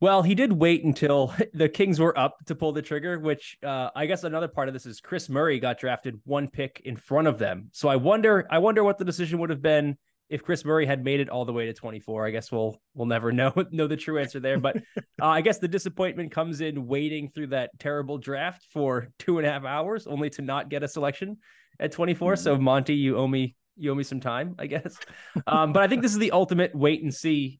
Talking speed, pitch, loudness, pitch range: 250 wpm, 150 Hz, -26 LUFS, 135-175 Hz